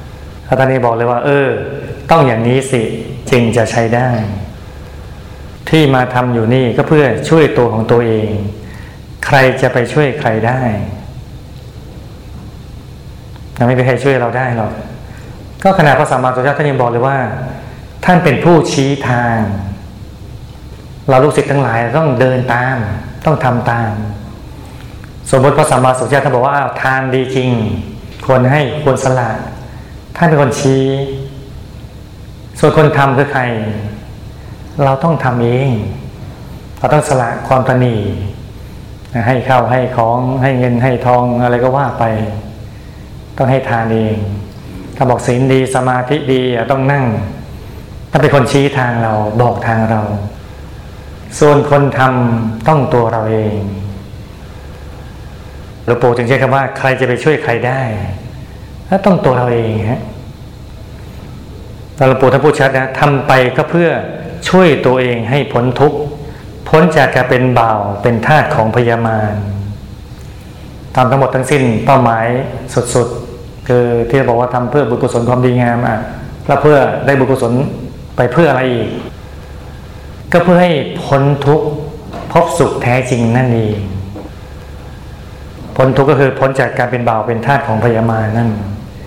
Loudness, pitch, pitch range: -12 LUFS, 125 Hz, 110-135 Hz